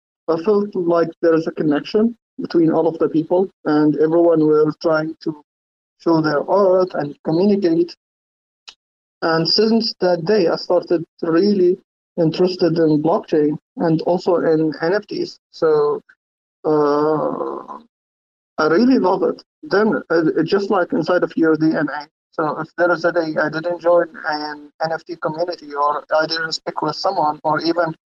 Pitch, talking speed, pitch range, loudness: 165 Hz, 150 wpm, 150-175 Hz, -18 LUFS